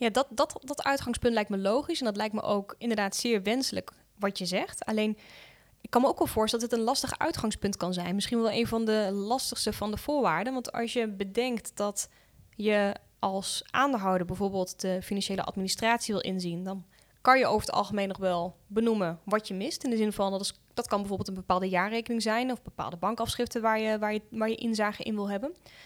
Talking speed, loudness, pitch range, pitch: 220 wpm, -30 LUFS, 195-235 Hz, 215 Hz